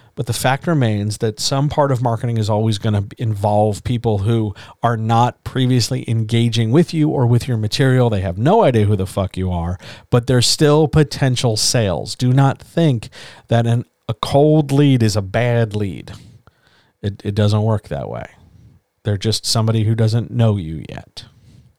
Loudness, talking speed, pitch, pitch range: -17 LUFS, 180 wpm, 115 Hz, 105-130 Hz